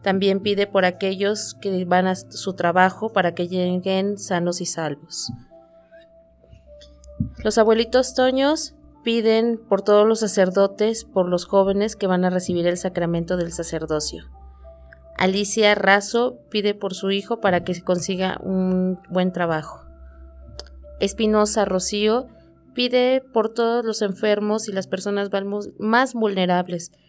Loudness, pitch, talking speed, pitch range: -21 LUFS, 190 Hz, 130 wpm, 175-215 Hz